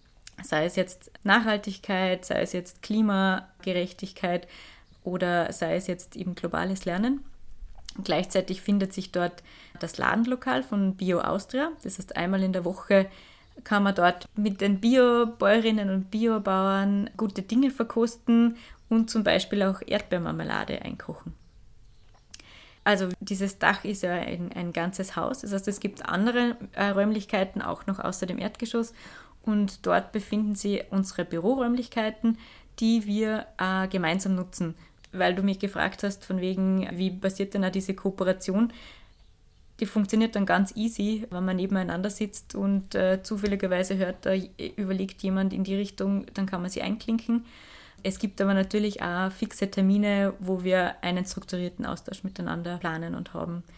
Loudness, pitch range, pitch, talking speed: -27 LUFS, 185-215 Hz, 195 Hz, 145 wpm